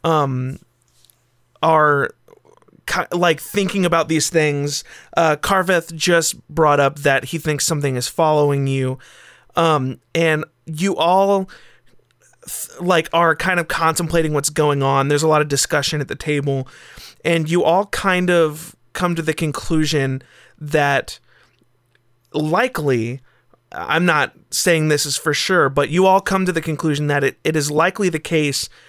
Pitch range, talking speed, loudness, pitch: 140-170 Hz, 145 wpm, -18 LUFS, 155 Hz